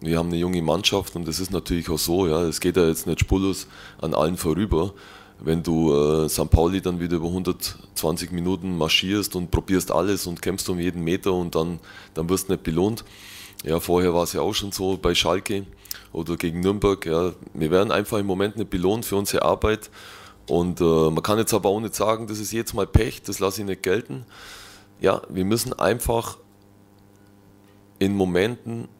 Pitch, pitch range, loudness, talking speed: 95 Hz, 85-100 Hz, -23 LUFS, 200 wpm